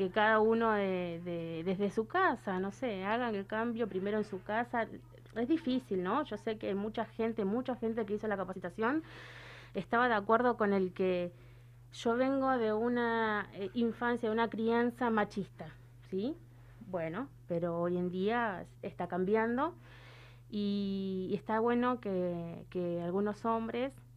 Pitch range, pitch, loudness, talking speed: 180-230 Hz, 205 Hz, -34 LUFS, 155 wpm